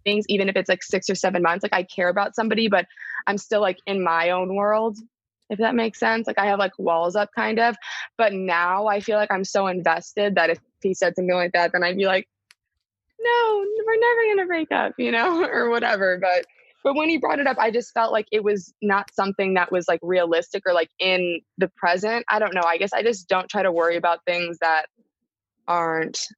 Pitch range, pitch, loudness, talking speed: 180-220 Hz, 195 Hz, -22 LUFS, 230 wpm